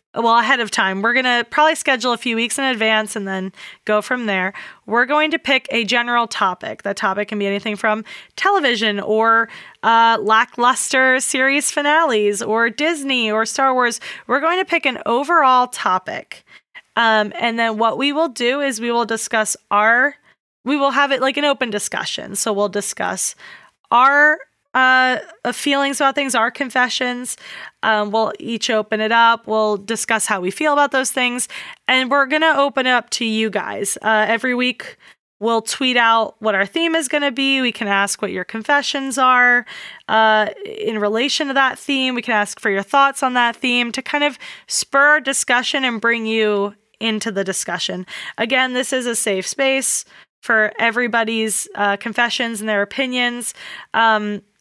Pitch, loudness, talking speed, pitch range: 240 Hz, -17 LUFS, 180 wpm, 220-270 Hz